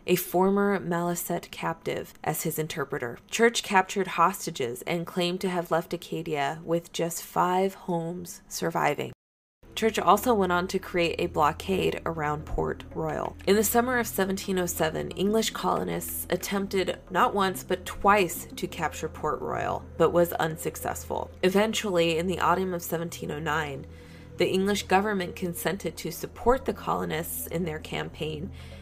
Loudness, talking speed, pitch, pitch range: -27 LUFS, 140 wpm, 175 Hz, 160-190 Hz